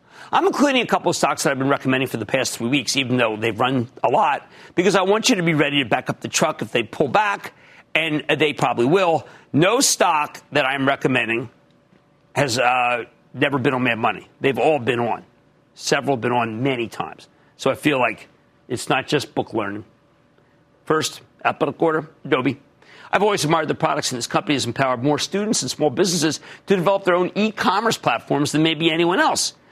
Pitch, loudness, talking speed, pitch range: 145 Hz, -20 LUFS, 205 wpm, 130-170 Hz